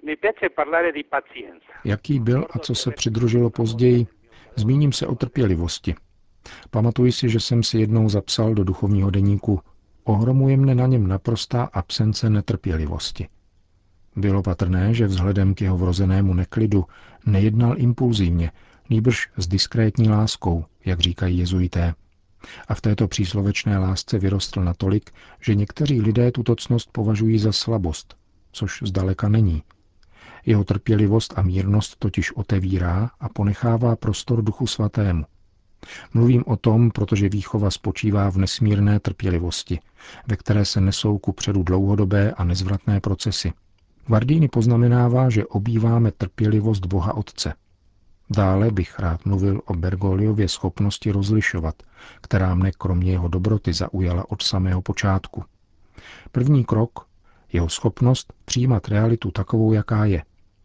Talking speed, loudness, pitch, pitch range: 125 wpm, -21 LUFS, 105 Hz, 95-115 Hz